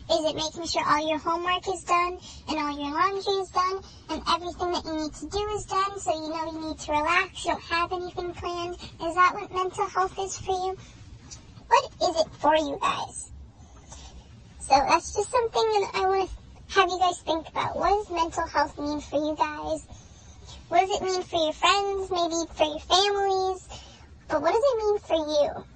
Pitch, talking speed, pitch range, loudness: 350 Hz, 205 wpm, 315-380 Hz, -26 LUFS